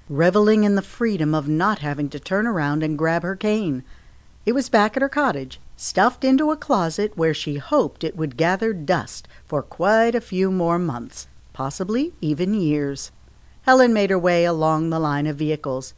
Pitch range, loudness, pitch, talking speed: 155-215 Hz, -21 LUFS, 175 Hz, 185 wpm